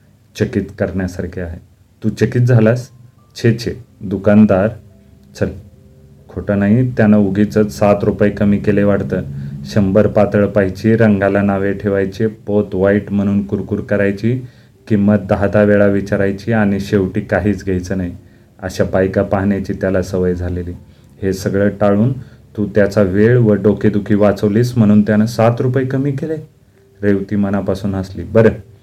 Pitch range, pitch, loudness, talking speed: 100-110 Hz, 105 Hz, -15 LUFS, 135 wpm